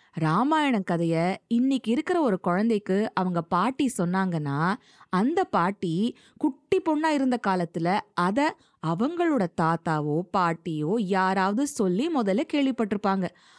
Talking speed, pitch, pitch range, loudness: 100 wpm, 195 Hz, 175-260 Hz, -26 LUFS